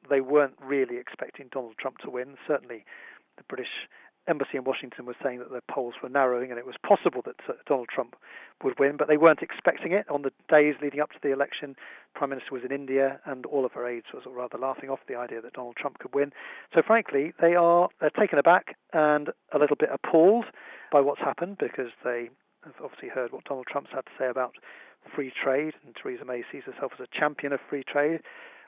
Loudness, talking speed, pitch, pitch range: -27 LUFS, 220 wpm, 140 Hz, 130-150 Hz